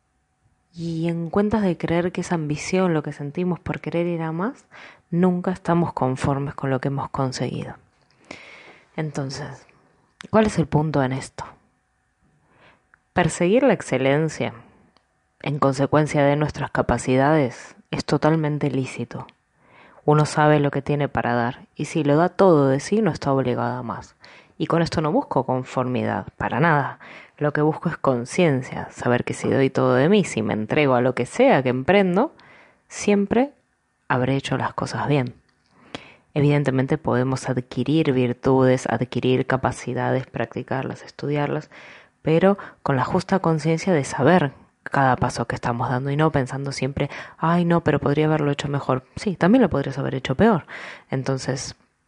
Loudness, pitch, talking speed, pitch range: -22 LUFS, 145 Hz, 155 wpm, 130-165 Hz